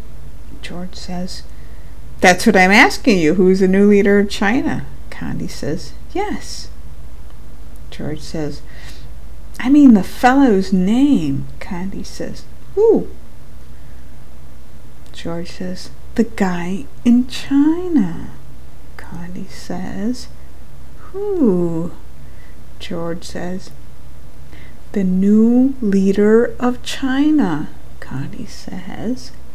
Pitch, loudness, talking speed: 185 Hz, -16 LUFS, 90 wpm